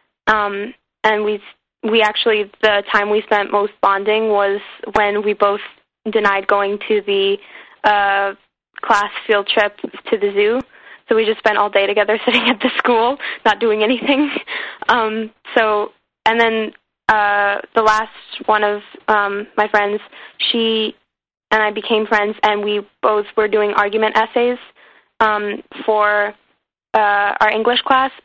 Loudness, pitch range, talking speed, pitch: -16 LUFS, 205-225 Hz, 150 wpm, 215 Hz